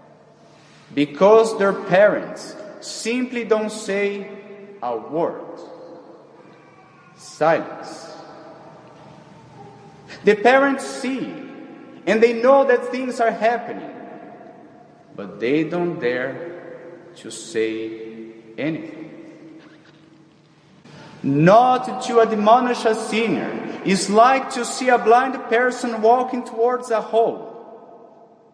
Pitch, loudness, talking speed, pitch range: 220 Hz, -19 LUFS, 90 wpm, 160-245 Hz